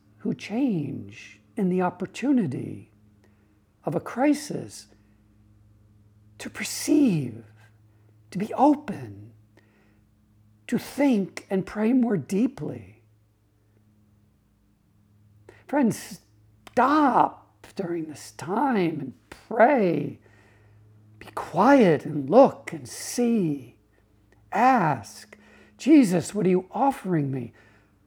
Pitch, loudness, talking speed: 110 Hz, -24 LUFS, 85 wpm